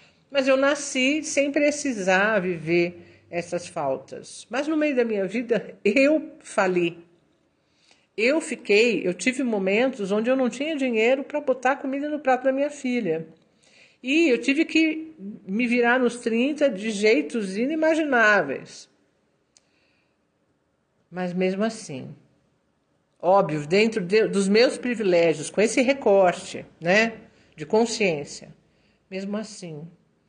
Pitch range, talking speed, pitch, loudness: 190-270 Hz, 125 wpm, 225 Hz, -23 LUFS